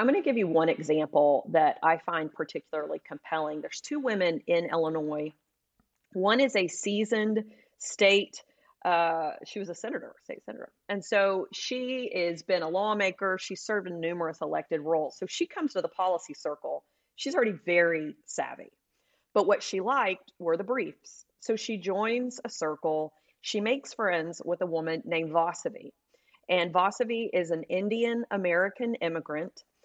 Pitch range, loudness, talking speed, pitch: 165-225 Hz, -29 LUFS, 160 wpm, 185 Hz